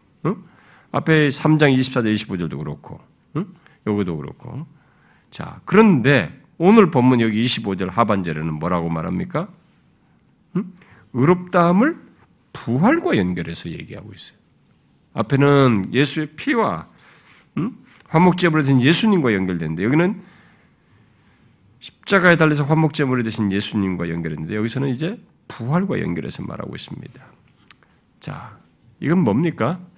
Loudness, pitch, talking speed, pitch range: -19 LUFS, 140 Hz, 270 characters per minute, 110-175 Hz